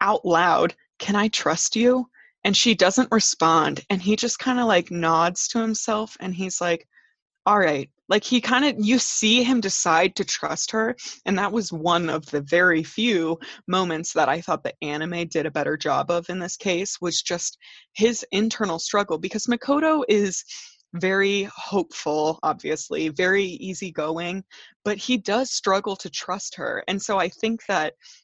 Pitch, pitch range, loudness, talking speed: 195 Hz, 175-225 Hz, -22 LUFS, 175 wpm